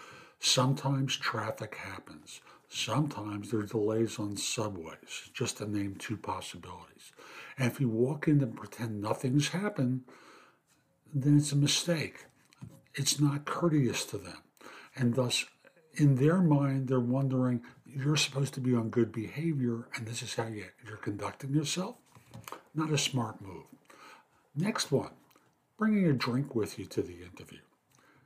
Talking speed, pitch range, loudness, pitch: 140 wpm, 115-145 Hz, -31 LUFS, 130 Hz